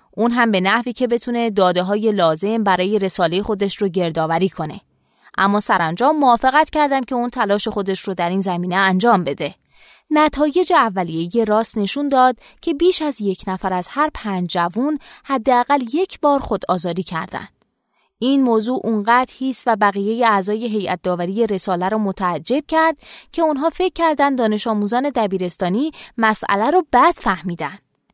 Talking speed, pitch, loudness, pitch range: 160 wpm, 220 Hz, -18 LUFS, 190-265 Hz